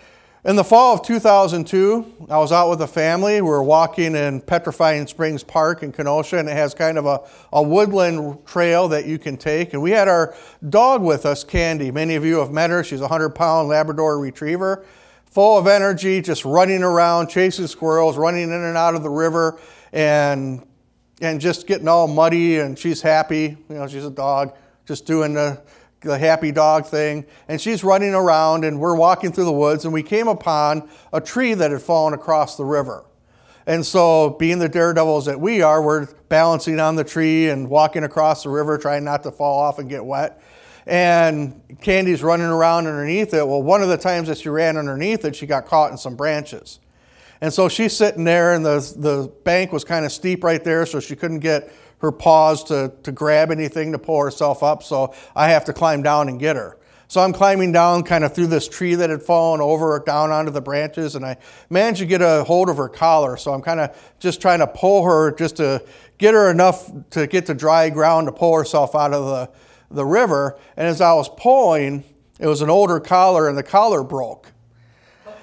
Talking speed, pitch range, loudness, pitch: 210 wpm, 150-170 Hz, -17 LUFS, 160 Hz